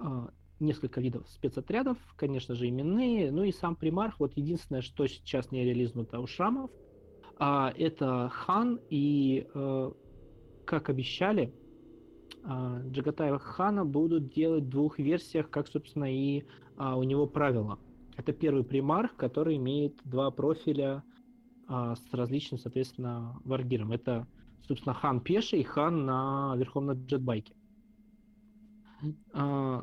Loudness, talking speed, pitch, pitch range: -32 LUFS, 115 wpm, 140 Hz, 130-165 Hz